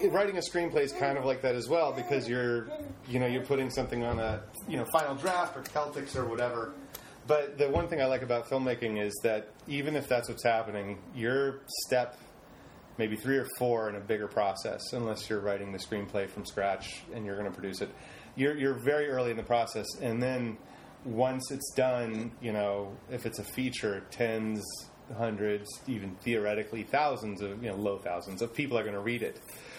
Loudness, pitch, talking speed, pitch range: -32 LUFS, 120 Hz, 195 wpm, 105-130 Hz